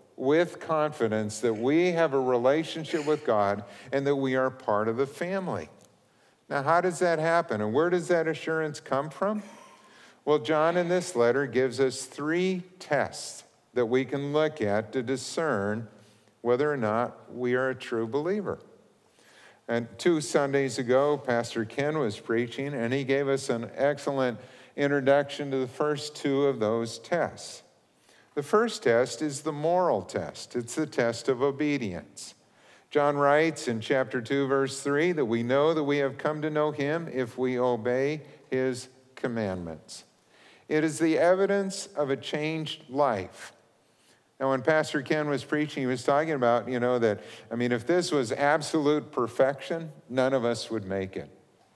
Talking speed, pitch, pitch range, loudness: 165 wpm, 140 Hz, 125-155 Hz, -28 LUFS